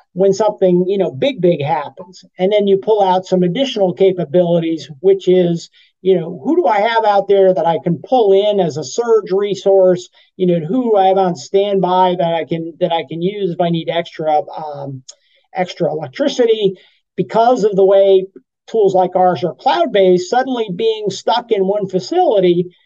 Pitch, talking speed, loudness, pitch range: 190 Hz, 185 wpm, -15 LUFS, 180-205 Hz